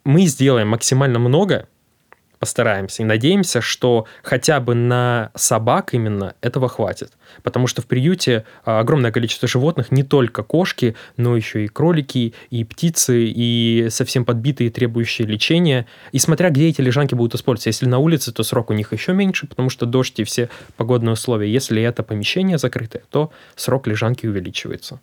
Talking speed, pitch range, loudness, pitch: 160 wpm, 115-135 Hz, -18 LUFS, 125 Hz